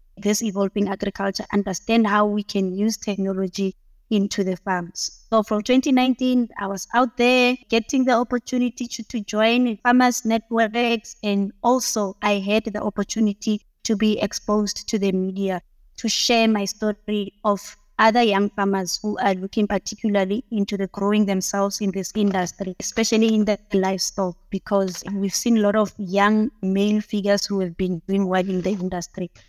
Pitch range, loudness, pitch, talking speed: 195-225 Hz, -22 LUFS, 205 Hz, 160 wpm